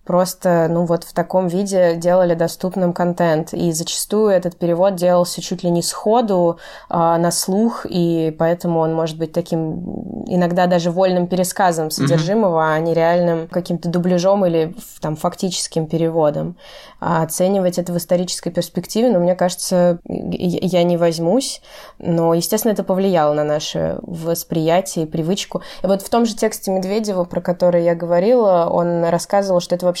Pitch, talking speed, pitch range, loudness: 175 Hz, 155 wpm, 170-190 Hz, -18 LUFS